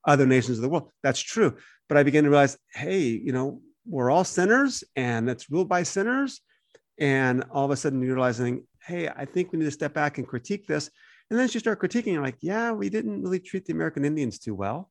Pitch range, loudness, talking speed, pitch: 130-185 Hz, -25 LUFS, 235 wpm, 150 Hz